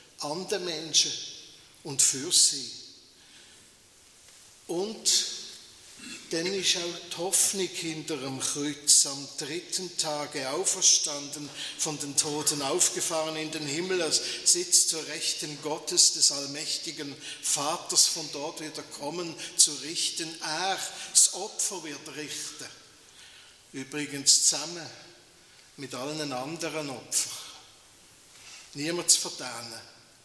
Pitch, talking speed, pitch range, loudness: 155 Hz, 105 wpm, 150-175 Hz, -26 LUFS